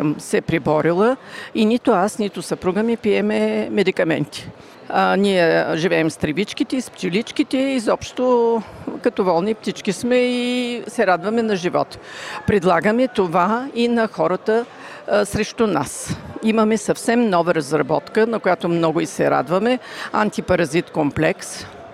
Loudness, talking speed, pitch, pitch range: -19 LUFS, 130 wpm, 215 Hz, 175-235 Hz